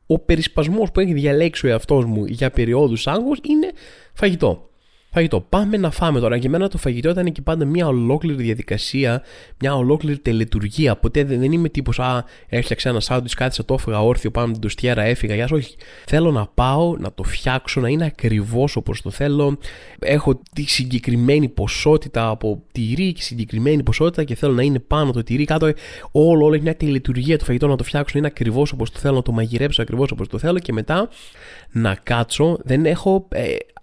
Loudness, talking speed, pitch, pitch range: -19 LUFS, 190 wpm, 135 Hz, 120-155 Hz